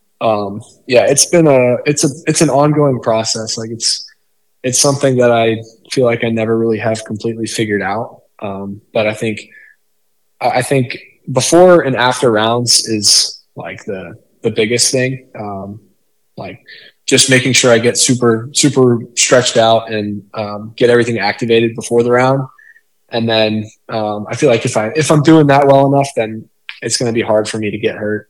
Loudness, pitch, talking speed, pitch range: -12 LUFS, 115 Hz, 180 wpm, 110-130 Hz